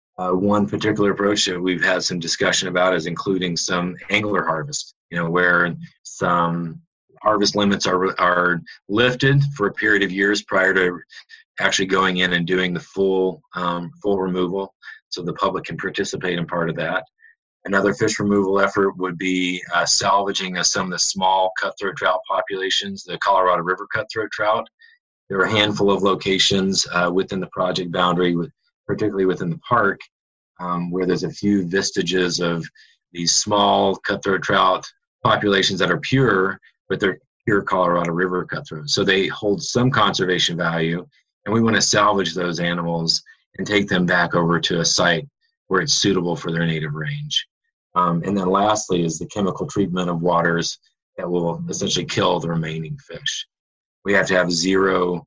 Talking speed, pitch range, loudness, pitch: 170 wpm, 90-100 Hz, -20 LUFS, 95 Hz